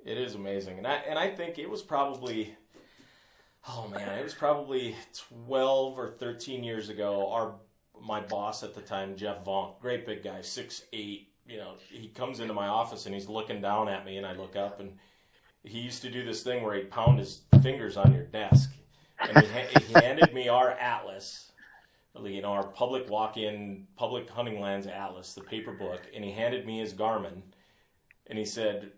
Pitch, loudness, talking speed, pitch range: 110 Hz, -29 LUFS, 200 wpm, 100-130 Hz